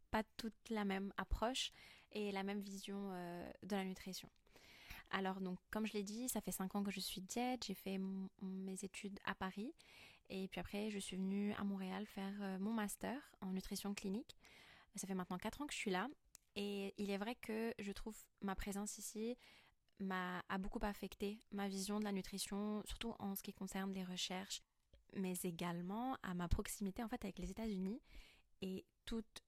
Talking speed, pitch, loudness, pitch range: 195 wpm, 200 Hz, -46 LUFS, 190-210 Hz